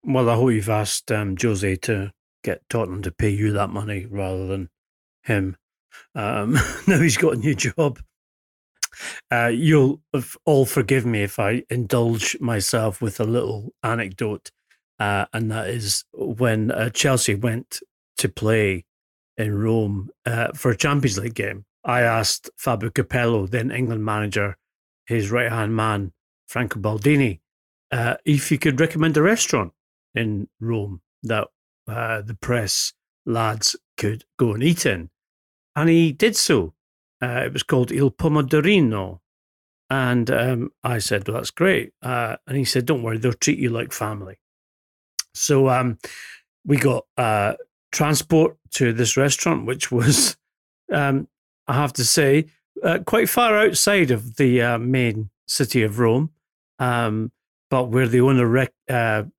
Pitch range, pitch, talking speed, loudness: 105-135 Hz, 120 Hz, 150 wpm, -21 LUFS